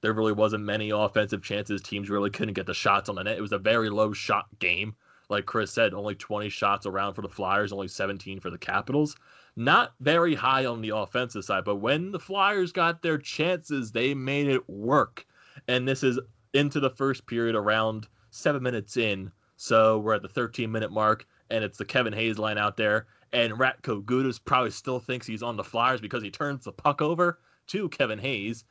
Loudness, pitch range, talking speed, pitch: -27 LUFS, 105-135 Hz, 210 wpm, 110 Hz